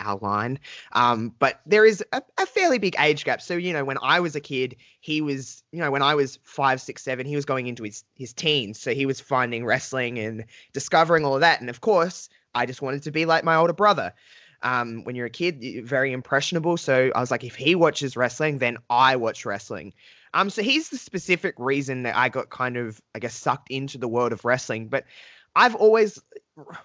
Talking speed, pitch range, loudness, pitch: 225 wpm, 125-170 Hz, -23 LUFS, 135 Hz